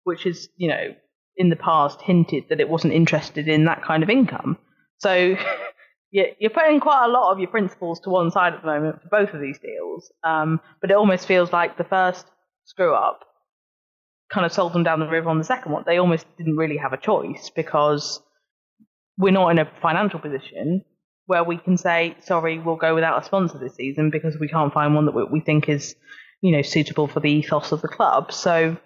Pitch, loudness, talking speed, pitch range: 165 Hz, -21 LUFS, 215 wpm, 155-185 Hz